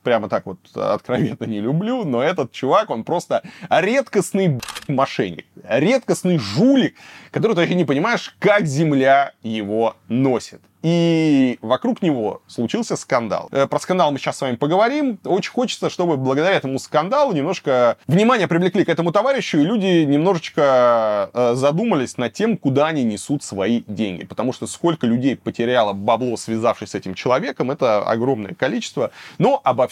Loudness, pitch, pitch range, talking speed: -19 LUFS, 145 Hz, 120-180 Hz, 150 wpm